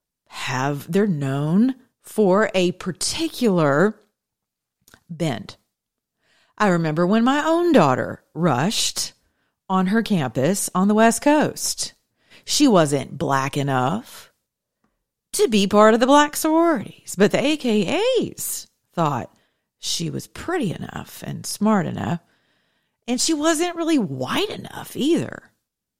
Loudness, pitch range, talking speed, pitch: -20 LUFS, 170-270 Hz, 115 wpm, 210 Hz